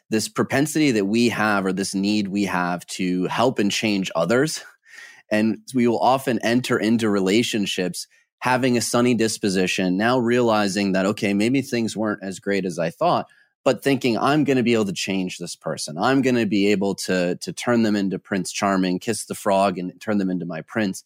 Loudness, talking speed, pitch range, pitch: -21 LUFS, 200 wpm, 95-120 Hz, 105 Hz